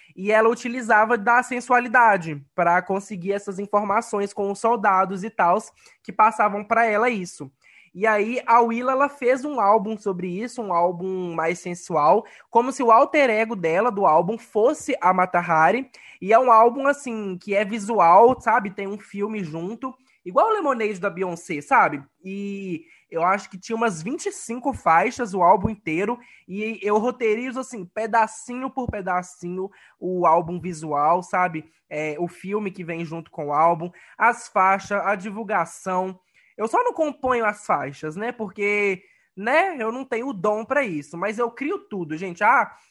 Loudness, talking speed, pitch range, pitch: -22 LUFS, 170 wpm, 180-235 Hz, 205 Hz